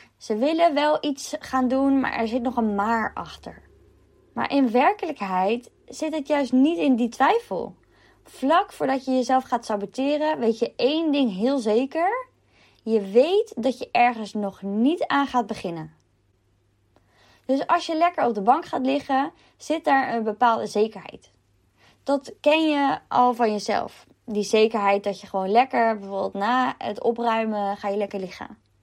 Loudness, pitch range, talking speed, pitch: -23 LUFS, 205-280 Hz, 165 wpm, 245 Hz